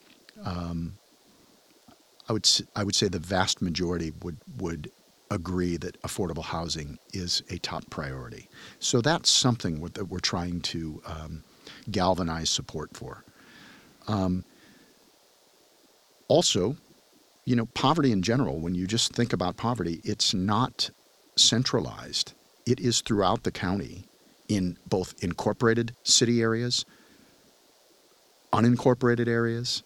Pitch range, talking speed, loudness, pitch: 85-115 Hz, 120 wpm, -26 LUFS, 95 Hz